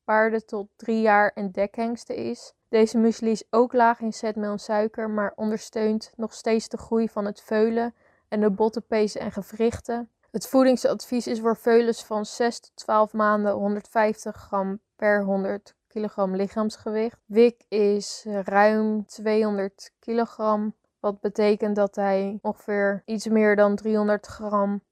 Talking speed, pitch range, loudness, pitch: 145 wpm, 205-225 Hz, -24 LUFS, 215 Hz